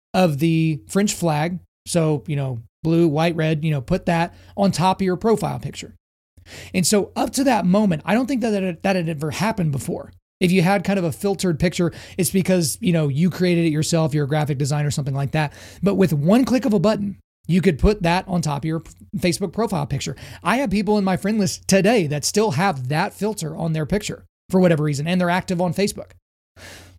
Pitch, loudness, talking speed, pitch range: 175 Hz, -20 LUFS, 225 wpm, 150-195 Hz